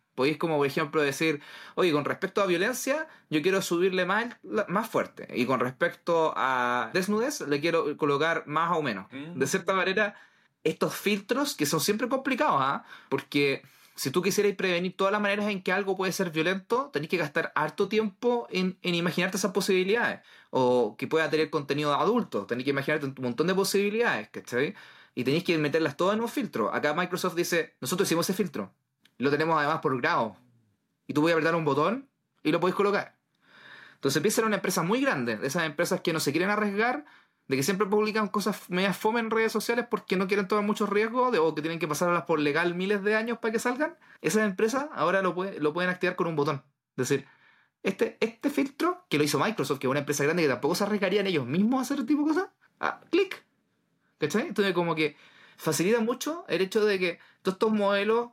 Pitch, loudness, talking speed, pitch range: 185 Hz, -27 LUFS, 210 wpm, 155-215 Hz